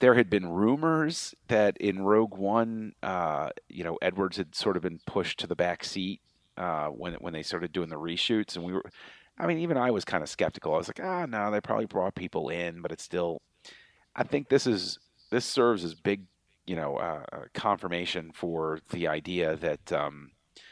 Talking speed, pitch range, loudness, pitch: 205 wpm, 85-110 Hz, -30 LUFS, 95 Hz